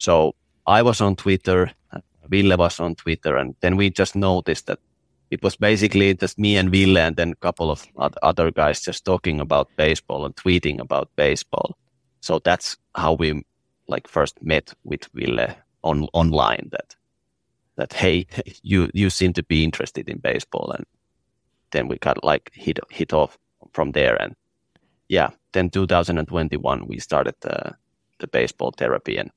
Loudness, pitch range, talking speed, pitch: -21 LUFS, 80-95 Hz, 165 wpm, 90 Hz